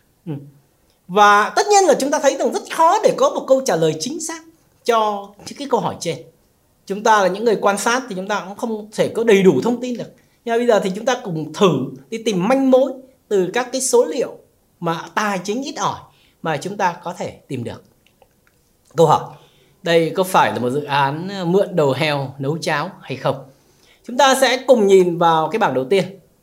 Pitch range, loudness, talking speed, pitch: 165-260 Hz, -18 LUFS, 225 wpm, 205 Hz